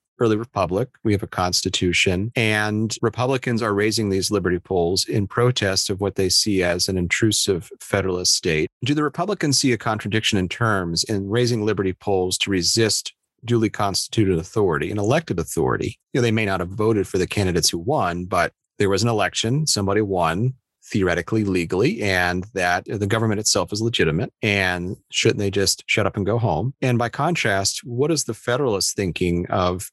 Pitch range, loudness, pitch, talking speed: 95-115 Hz, -21 LUFS, 105 Hz, 180 wpm